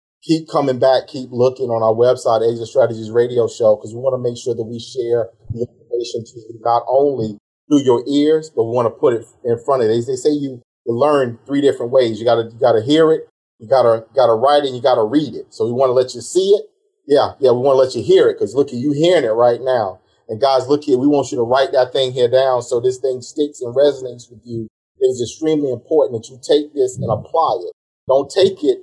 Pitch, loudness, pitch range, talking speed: 130 Hz, -16 LUFS, 120-150 Hz, 250 wpm